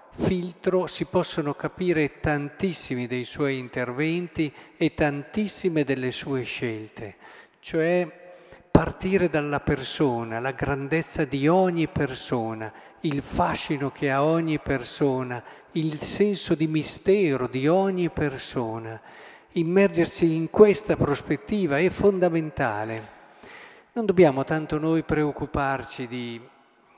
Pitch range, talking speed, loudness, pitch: 135-170 Hz, 105 wpm, -25 LUFS, 150 Hz